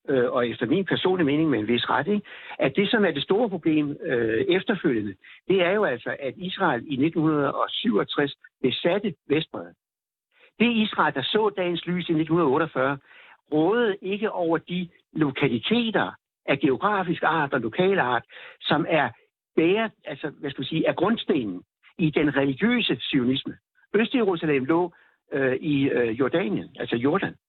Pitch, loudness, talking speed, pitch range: 175 Hz, -24 LUFS, 150 wpm, 145-205 Hz